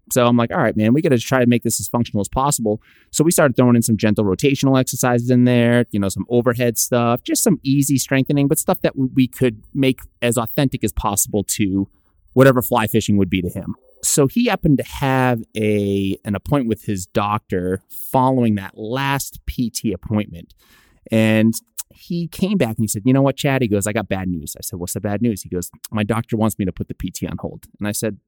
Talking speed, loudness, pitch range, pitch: 230 wpm, -18 LUFS, 105-130 Hz, 115 Hz